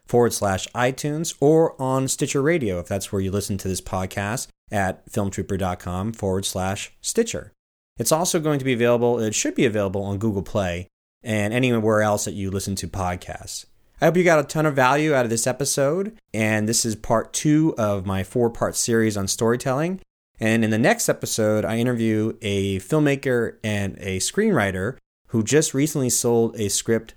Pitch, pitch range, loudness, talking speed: 110 Hz, 100-130 Hz, -22 LUFS, 185 wpm